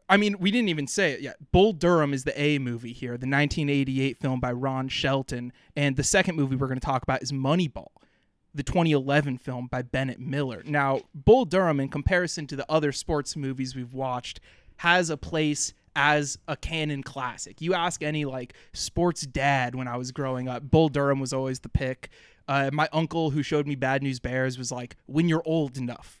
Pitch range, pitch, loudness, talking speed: 130-155 Hz, 140 Hz, -26 LUFS, 205 wpm